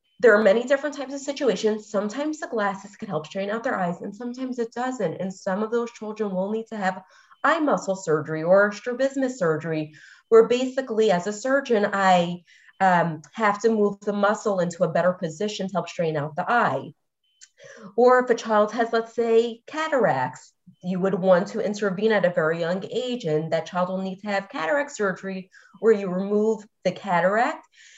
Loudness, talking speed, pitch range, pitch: -23 LUFS, 190 wpm, 185-235 Hz, 210 Hz